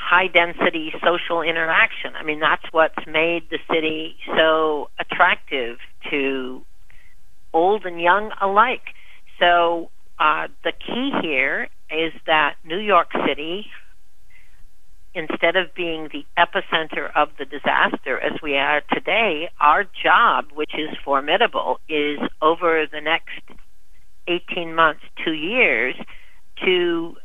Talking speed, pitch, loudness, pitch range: 120 wpm, 165 Hz, -20 LUFS, 155-175 Hz